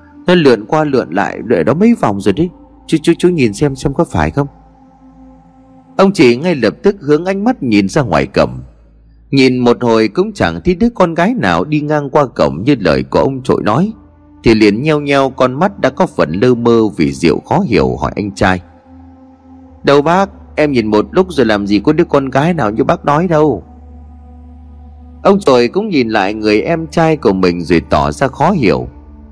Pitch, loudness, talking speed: 130 Hz, -12 LUFS, 210 wpm